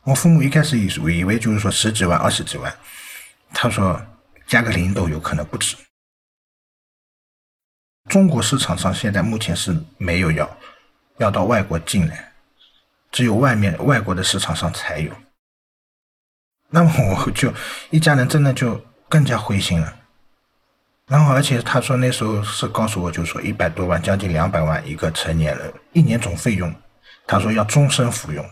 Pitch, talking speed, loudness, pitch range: 110 Hz, 245 characters per minute, -19 LUFS, 90-130 Hz